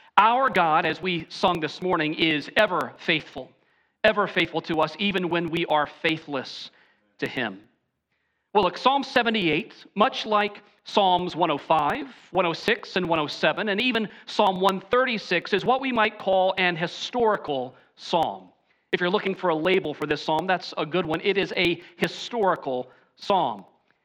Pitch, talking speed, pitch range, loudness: 180 Hz, 155 wpm, 160-205 Hz, -24 LUFS